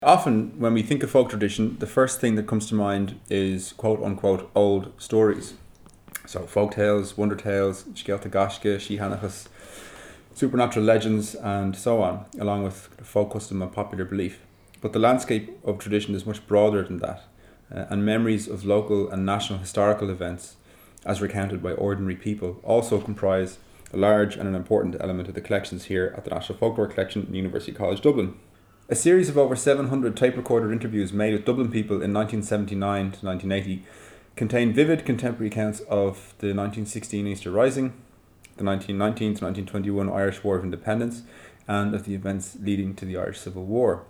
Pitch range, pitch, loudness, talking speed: 95-110 Hz, 105 Hz, -25 LUFS, 170 wpm